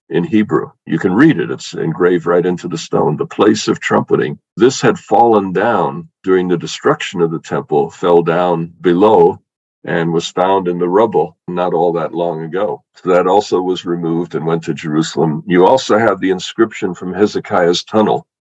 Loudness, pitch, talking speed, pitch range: -14 LUFS, 85 Hz, 185 wpm, 85-90 Hz